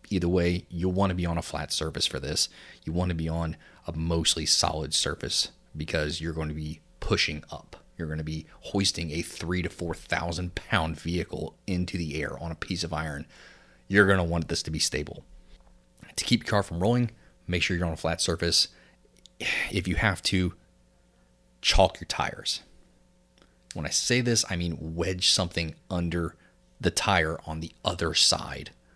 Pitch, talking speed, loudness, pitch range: 85 Hz, 190 wpm, -27 LUFS, 80-90 Hz